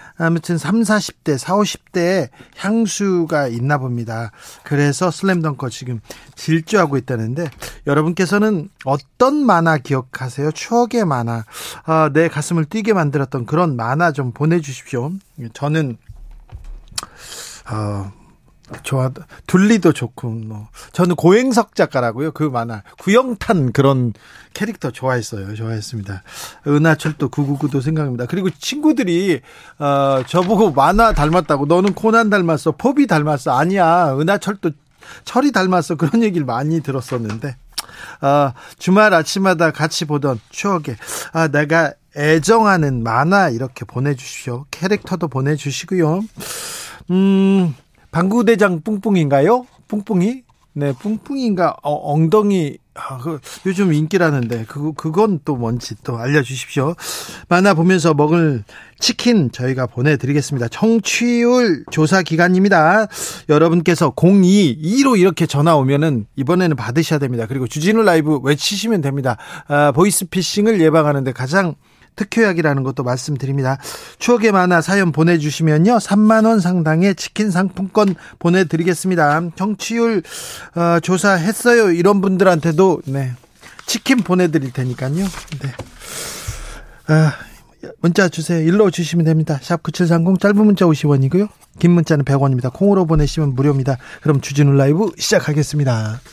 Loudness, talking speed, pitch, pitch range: -16 LUFS, 300 characters per minute, 160 Hz, 140-190 Hz